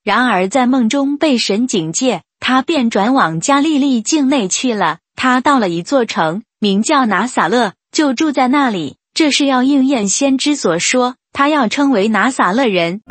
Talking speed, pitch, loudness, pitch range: 245 characters per minute, 255 Hz, -14 LUFS, 205-275 Hz